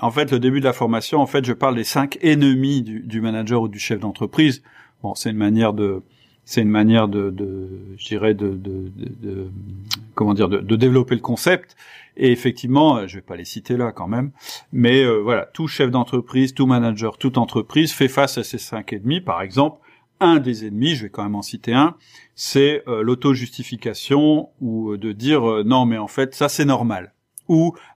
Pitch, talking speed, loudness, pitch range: 120 Hz, 210 wpm, -19 LUFS, 110-135 Hz